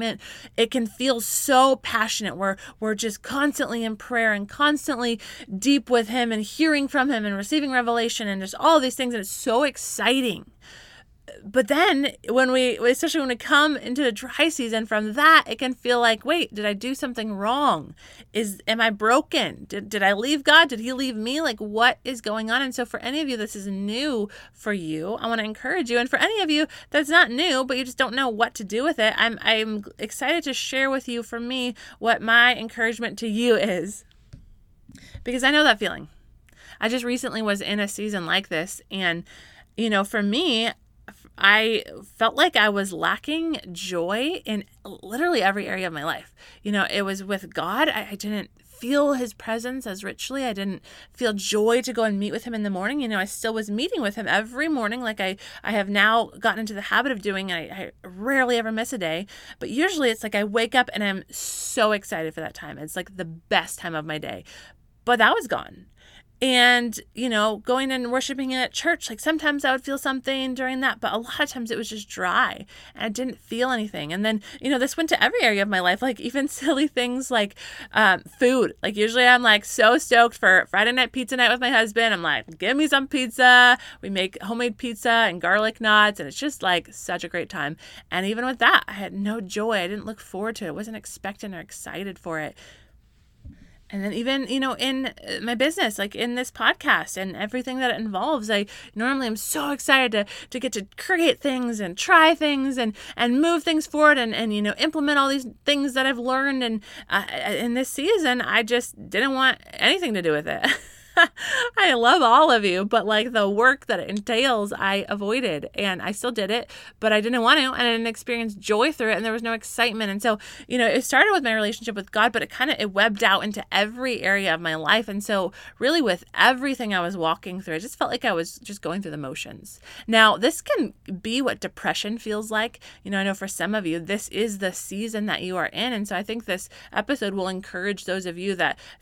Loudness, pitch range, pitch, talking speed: -22 LUFS, 205-260 Hz, 230 Hz, 225 wpm